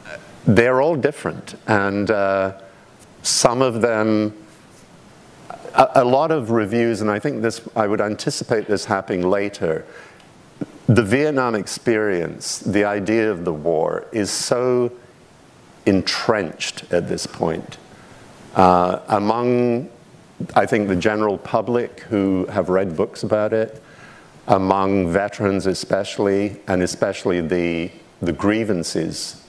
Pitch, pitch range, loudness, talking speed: 105 Hz, 95-120 Hz, -20 LUFS, 120 wpm